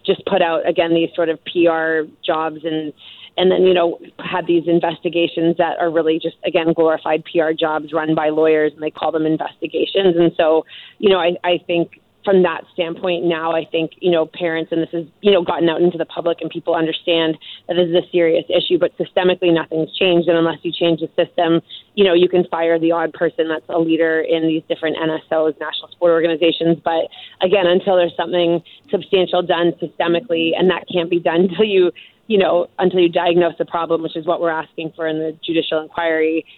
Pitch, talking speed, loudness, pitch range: 170 Hz, 210 wpm, -17 LUFS, 160-175 Hz